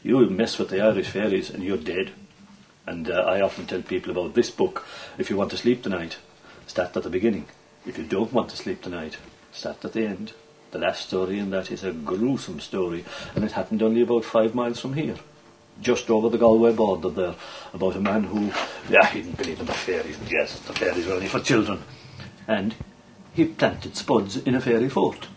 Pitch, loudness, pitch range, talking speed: 110 Hz, -24 LUFS, 95-120 Hz, 210 wpm